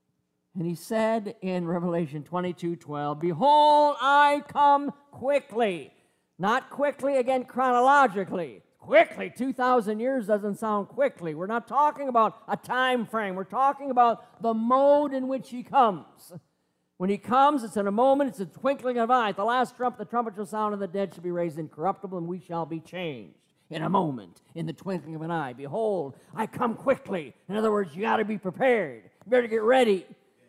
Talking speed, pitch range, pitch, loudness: 185 wpm, 180-255 Hz, 220 Hz, -26 LUFS